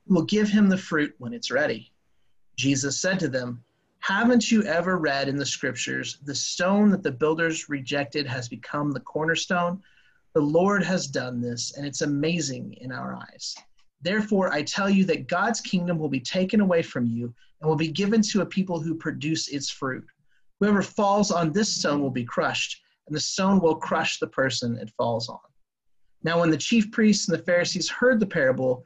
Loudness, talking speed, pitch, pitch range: -25 LUFS, 195 wpm, 160 Hz, 140-190 Hz